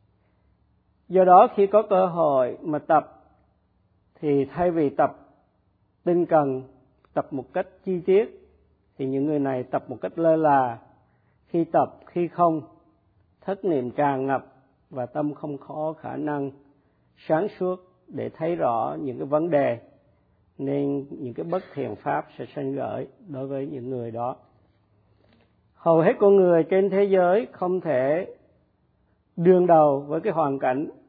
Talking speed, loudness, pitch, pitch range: 155 wpm, -23 LUFS, 145 Hz, 130-180 Hz